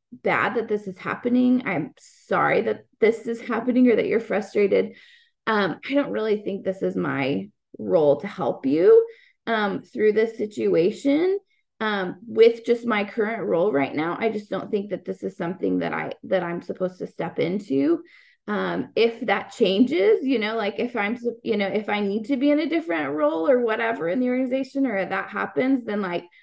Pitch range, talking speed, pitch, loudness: 195-265 Hz, 195 wpm, 225 Hz, -23 LUFS